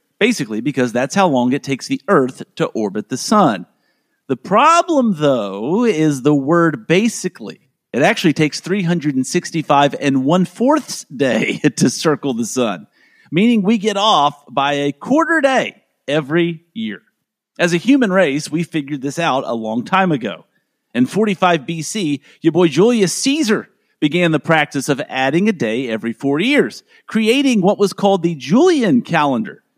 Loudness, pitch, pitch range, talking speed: -16 LUFS, 170 Hz, 145-215 Hz, 155 wpm